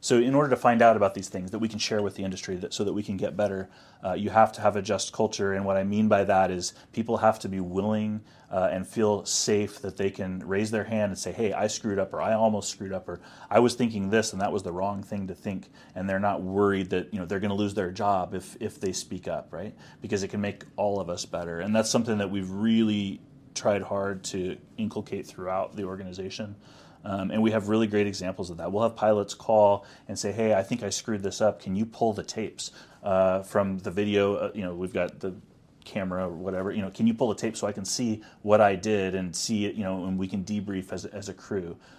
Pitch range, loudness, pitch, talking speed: 95-110 Hz, -27 LUFS, 100 Hz, 265 wpm